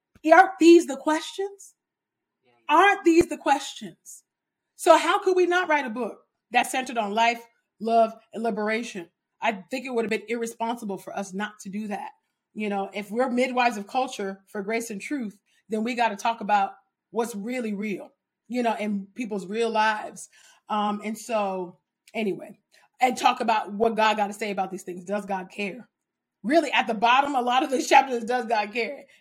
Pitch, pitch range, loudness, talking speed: 225 Hz, 205-255 Hz, -24 LUFS, 190 wpm